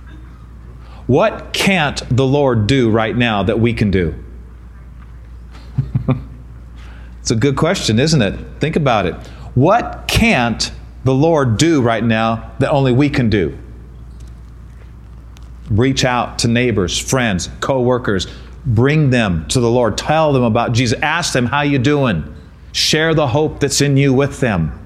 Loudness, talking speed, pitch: -15 LUFS, 145 wpm, 115 Hz